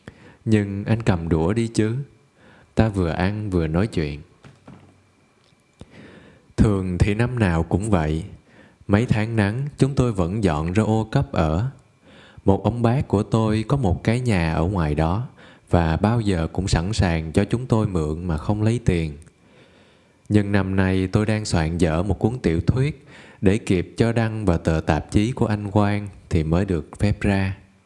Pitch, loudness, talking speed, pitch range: 100 Hz, -22 LUFS, 175 wpm, 90-110 Hz